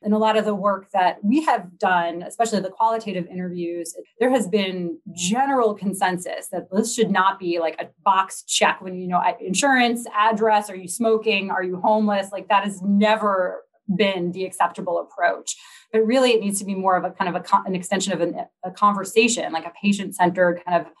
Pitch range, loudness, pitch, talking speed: 180-215 Hz, -21 LUFS, 195 Hz, 205 wpm